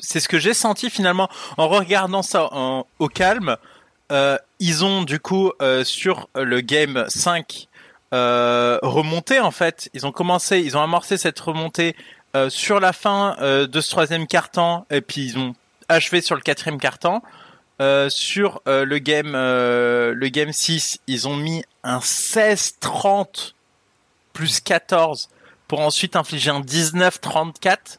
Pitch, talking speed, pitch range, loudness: 160 Hz, 155 wpm, 135-180 Hz, -19 LUFS